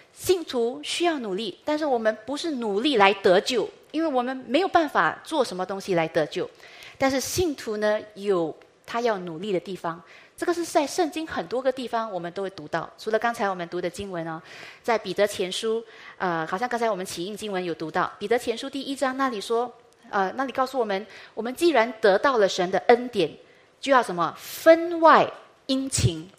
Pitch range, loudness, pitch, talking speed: 185-275 Hz, -25 LUFS, 230 Hz, 295 characters per minute